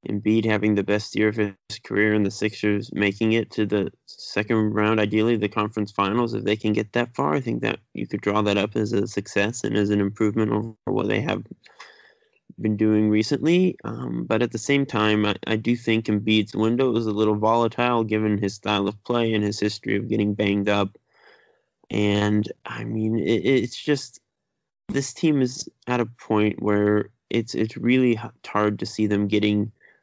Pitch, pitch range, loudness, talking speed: 105 Hz, 105-115 Hz, -23 LUFS, 195 wpm